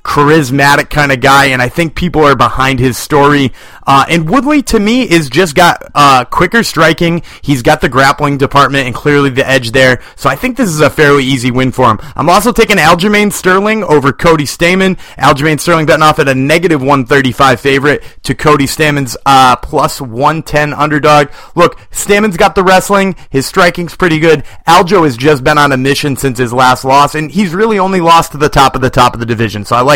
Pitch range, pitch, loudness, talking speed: 135-170 Hz, 150 Hz, -8 LUFS, 215 wpm